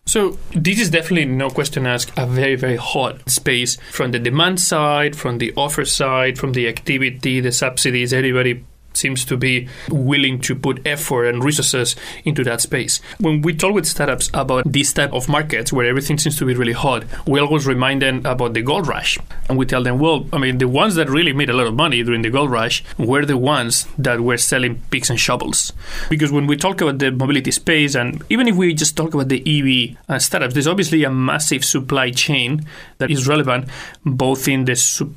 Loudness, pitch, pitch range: -17 LUFS, 135 Hz, 125-150 Hz